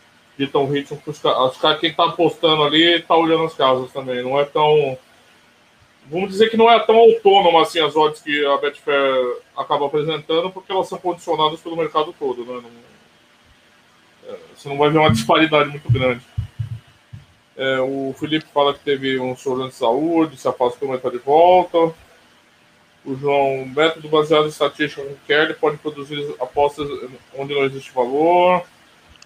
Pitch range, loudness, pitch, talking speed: 135-160 Hz, -18 LUFS, 150 Hz, 170 wpm